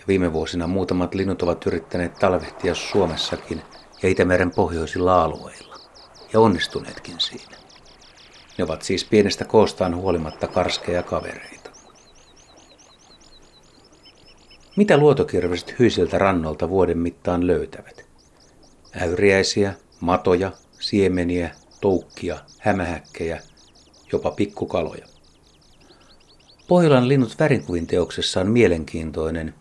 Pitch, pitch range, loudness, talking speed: 90 Hz, 80-95 Hz, -21 LUFS, 85 wpm